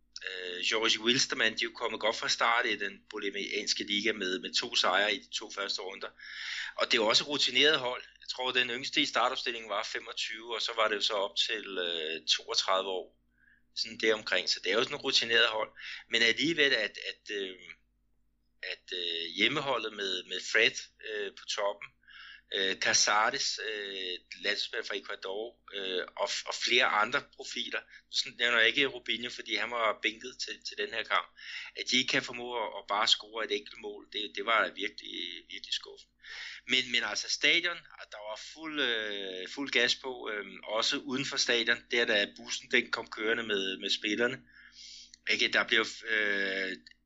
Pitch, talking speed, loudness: 135 Hz, 180 wpm, -30 LUFS